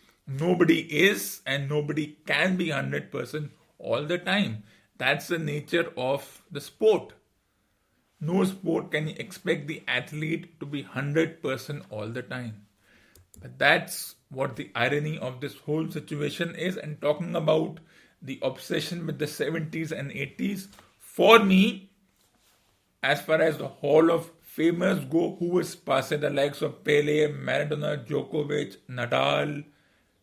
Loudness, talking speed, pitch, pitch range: -27 LUFS, 135 wpm, 155 Hz, 145-170 Hz